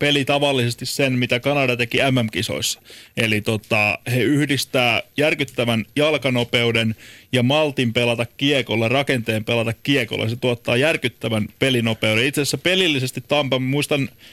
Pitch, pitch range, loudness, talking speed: 125 Hz, 115-140 Hz, -19 LUFS, 120 wpm